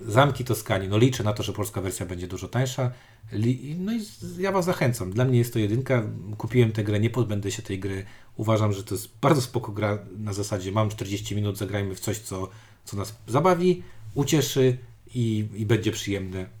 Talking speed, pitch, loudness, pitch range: 195 wpm, 110 Hz, -26 LUFS, 105-125 Hz